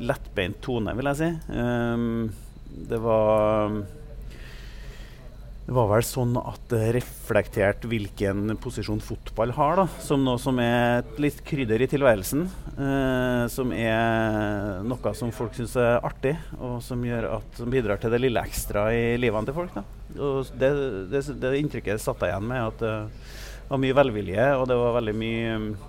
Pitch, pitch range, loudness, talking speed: 120 Hz, 110-135 Hz, -25 LUFS, 170 wpm